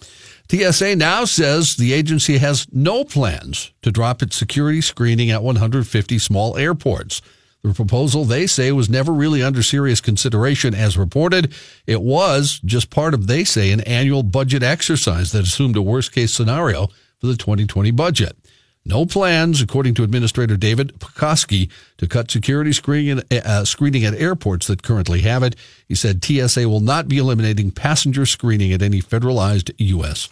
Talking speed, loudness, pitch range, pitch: 160 wpm, -17 LUFS, 105-140 Hz, 125 Hz